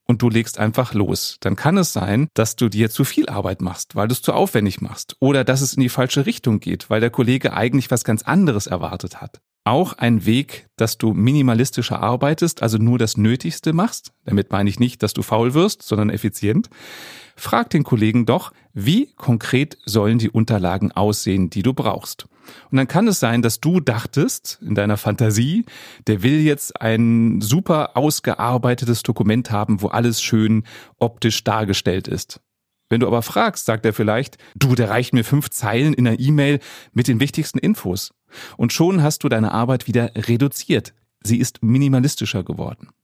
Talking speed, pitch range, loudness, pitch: 185 wpm, 110-135 Hz, -19 LUFS, 120 Hz